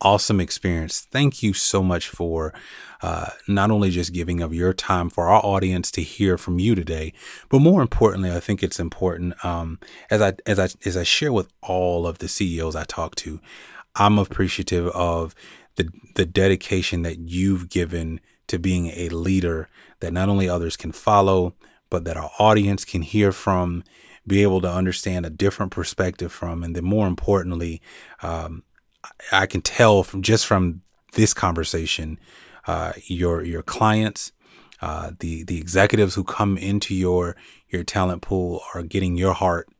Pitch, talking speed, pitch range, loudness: 90 Hz, 170 wpm, 85-100 Hz, -22 LUFS